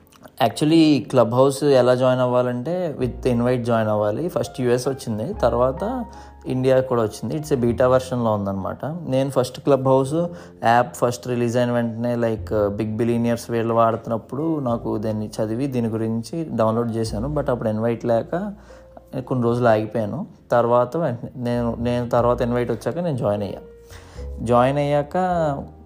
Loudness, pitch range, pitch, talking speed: -21 LUFS, 115-135 Hz, 120 Hz, 140 wpm